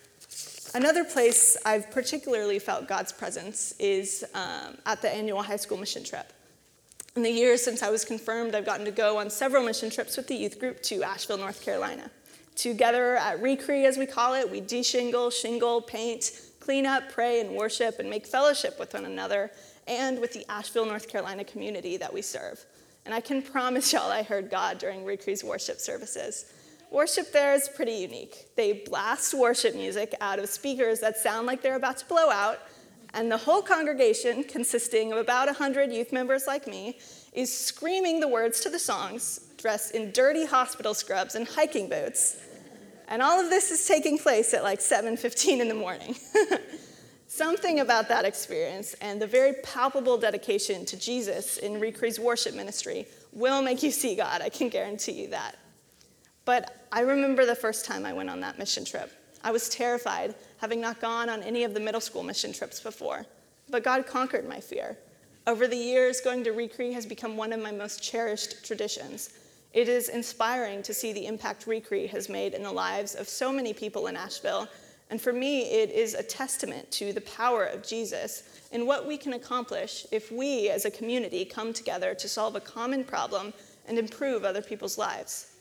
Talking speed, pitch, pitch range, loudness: 190 wpm, 245 Hz, 225-275 Hz, -28 LUFS